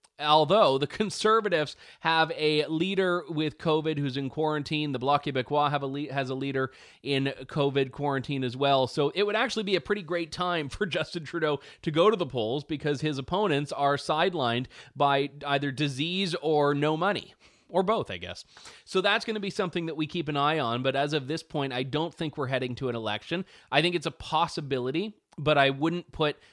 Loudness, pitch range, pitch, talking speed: -28 LUFS, 140-170 Hz, 150 Hz, 205 wpm